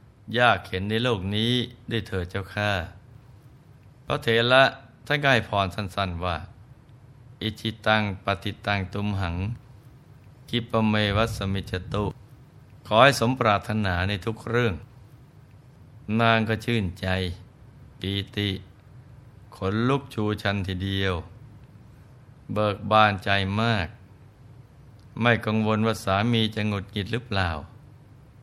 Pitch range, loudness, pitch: 100-120 Hz, -25 LUFS, 110 Hz